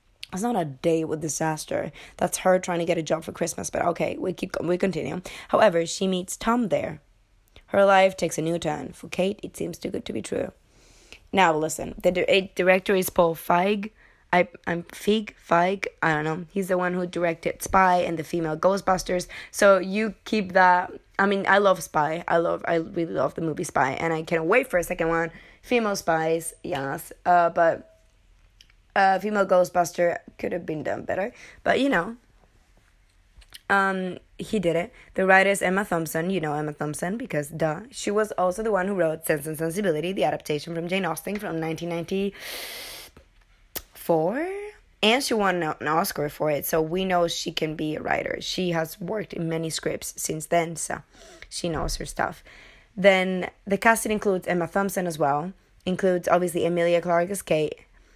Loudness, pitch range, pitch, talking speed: -24 LUFS, 160-190 Hz, 175 Hz, 185 wpm